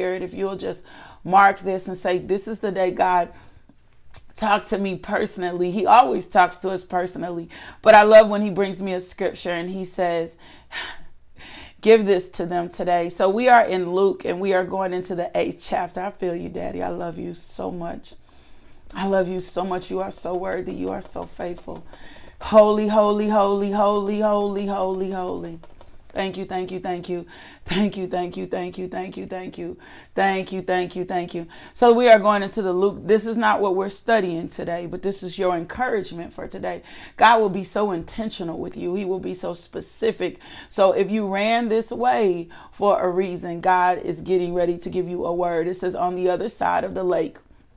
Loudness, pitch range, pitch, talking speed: -21 LUFS, 180-205 Hz, 185 Hz, 205 wpm